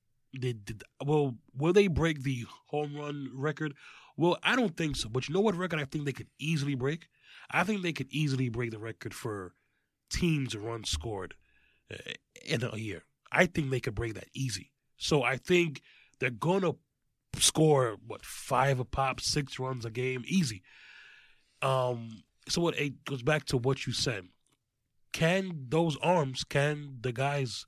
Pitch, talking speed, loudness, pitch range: 135 Hz, 170 wpm, -31 LUFS, 125-155 Hz